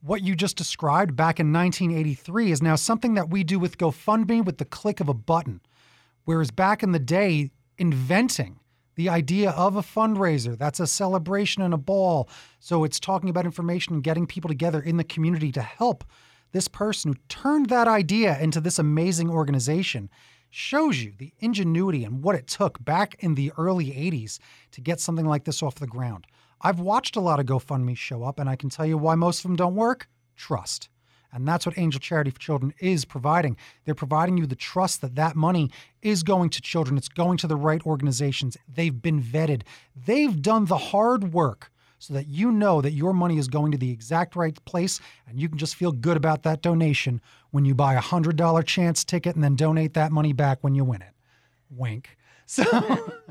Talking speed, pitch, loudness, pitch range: 205 wpm, 160 Hz, -24 LUFS, 140-180 Hz